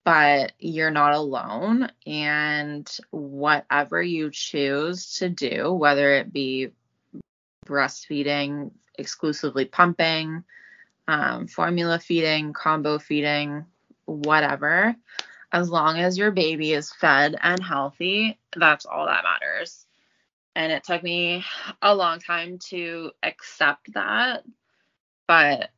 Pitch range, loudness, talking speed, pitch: 145-175 Hz, -22 LUFS, 105 wpm, 155 Hz